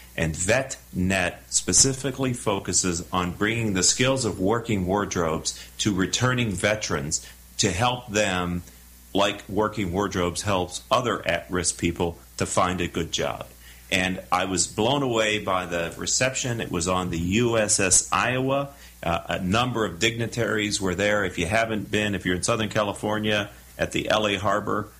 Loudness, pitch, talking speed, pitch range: -24 LUFS, 100 Hz, 155 wpm, 90-110 Hz